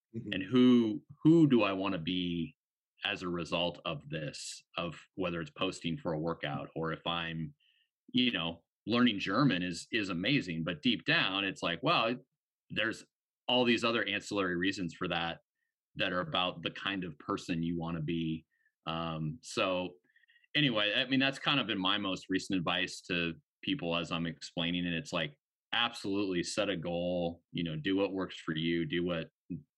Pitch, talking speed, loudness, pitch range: 90 Hz, 180 wpm, -33 LUFS, 85-105 Hz